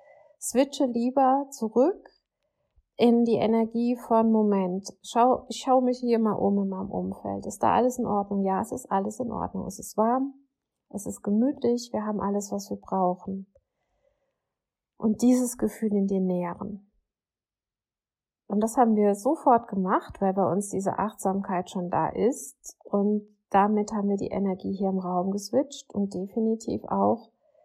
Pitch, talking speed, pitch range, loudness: 210 Hz, 160 wpm, 195-245 Hz, -26 LUFS